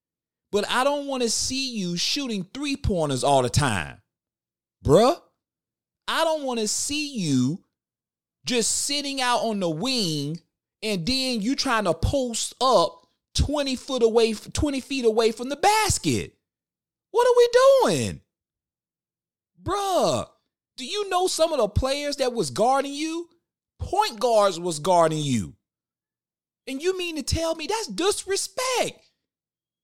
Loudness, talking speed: -23 LUFS, 140 wpm